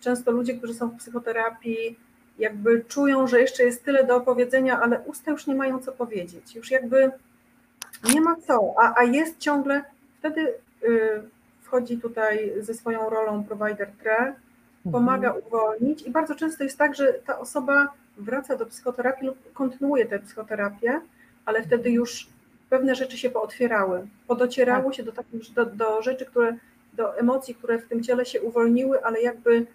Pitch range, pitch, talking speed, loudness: 230-265 Hz, 245 Hz, 160 wpm, -24 LUFS